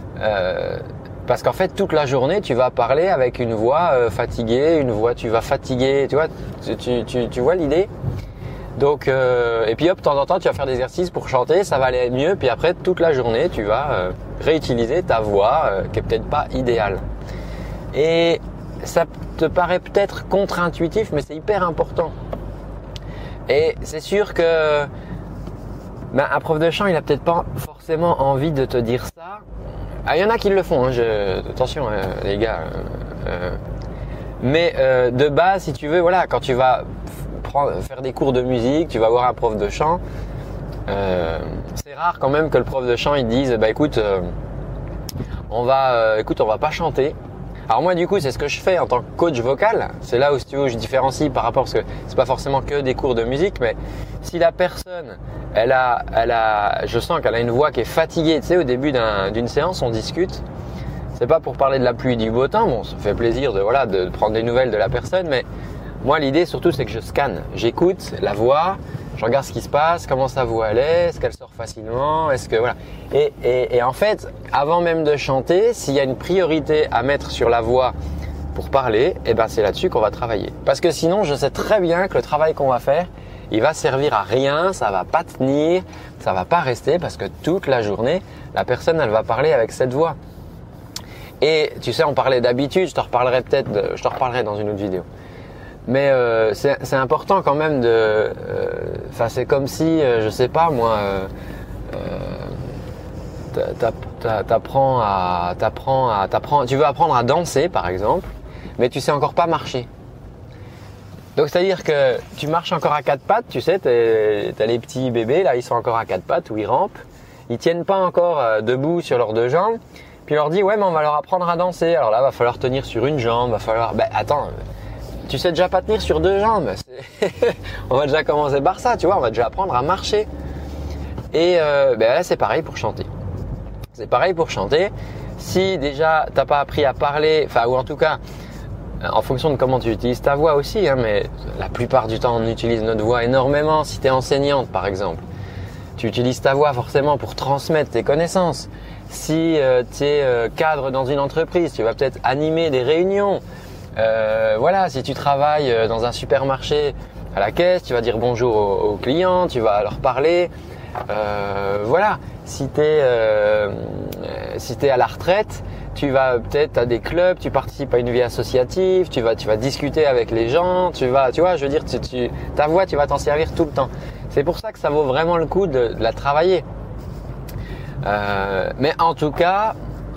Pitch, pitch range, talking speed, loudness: 135 Hz, 115-165 Hz, 210 wpm, -19 LUFS